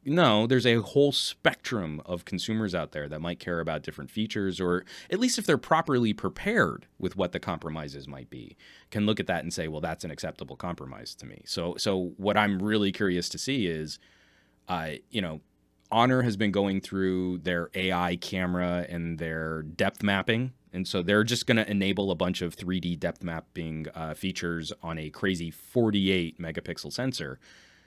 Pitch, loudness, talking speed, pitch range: 95 Hz, -29 LUFS, 185 wpm, 85-105 Hz